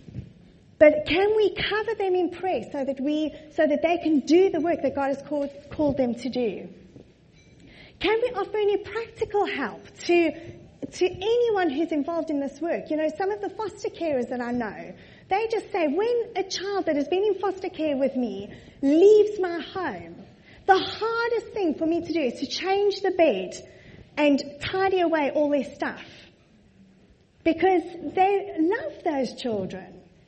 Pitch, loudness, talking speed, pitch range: 335 Hz, -25 LUFS, 175 wpm, 290-390 Hz